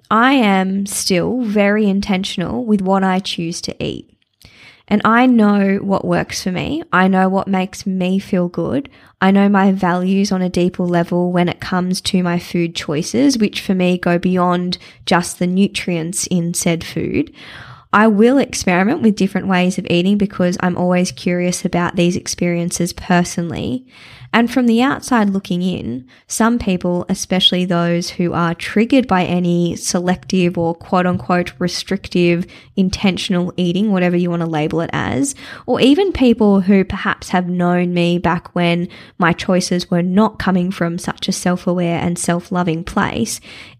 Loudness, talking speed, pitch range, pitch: -16 LUFS, 165 wpm, 175-195 Hz, 180 Hz